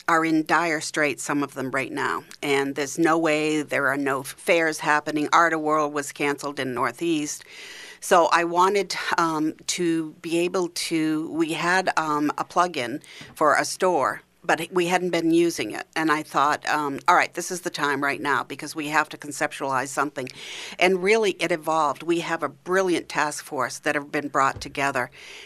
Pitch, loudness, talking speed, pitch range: 155 Hz, -23 LUFS, 190 wpm, 145-170 Hz